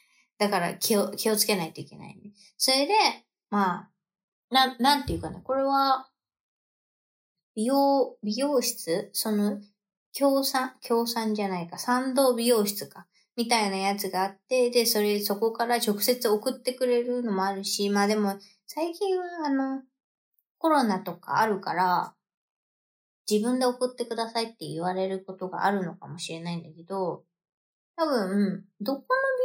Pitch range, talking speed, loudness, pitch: 195-255 Hz, 290 characters per minute, -26 LUFS, 215 Hz